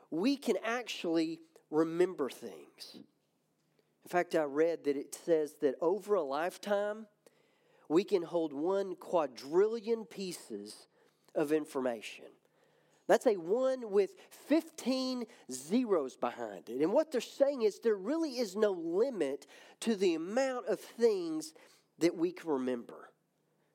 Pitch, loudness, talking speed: 230 Hz, -34 LUFS, 130 wpm